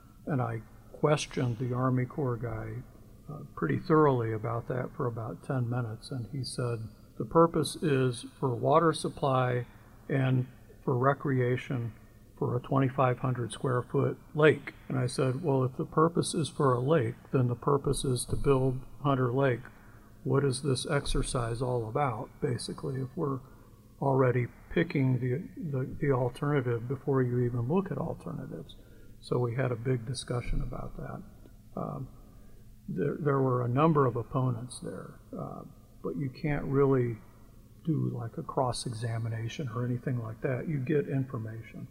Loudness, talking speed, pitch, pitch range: -31 LUFS, 155 wpm, 130 Hz, 115-140 Hz